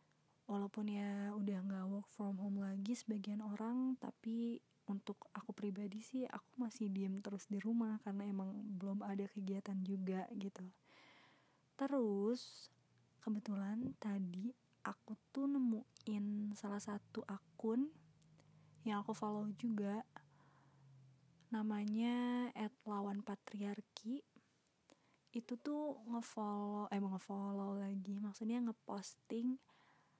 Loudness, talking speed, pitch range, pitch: -44 LUFS, 105 wpm, 200-225 Hz, 205 Hz